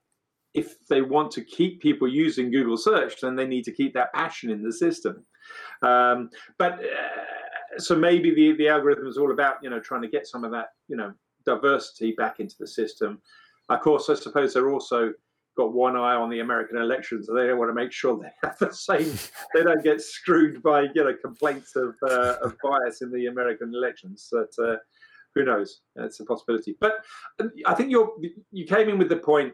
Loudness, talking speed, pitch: -24 LUFS, 205 wpm, 165 Hz